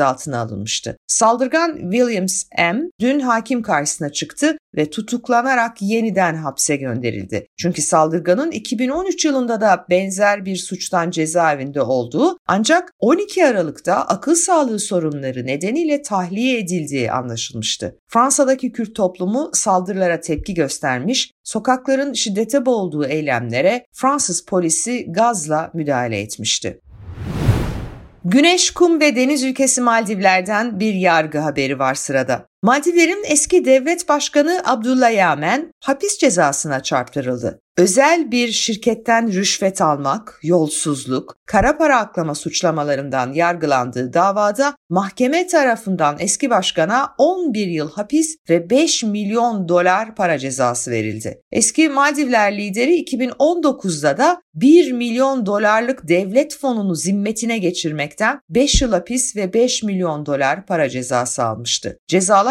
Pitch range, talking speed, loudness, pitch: 160-260 Hz, 115 wpm, -17 LUFS, 205 Hz